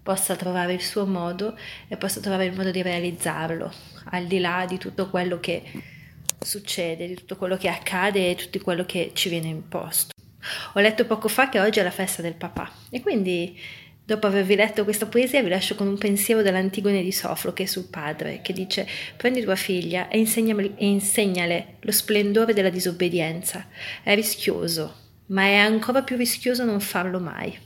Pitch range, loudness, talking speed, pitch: 180-210 Hz, -24 LUFS, 180 wpm, 190 Hz